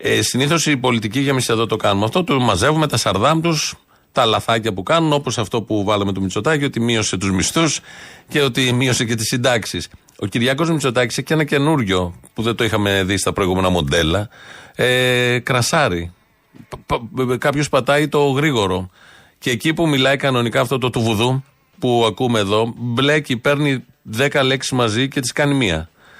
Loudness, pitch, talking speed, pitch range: -17 LUFS, 125 Hz, 175 wpm, 110-140 Hz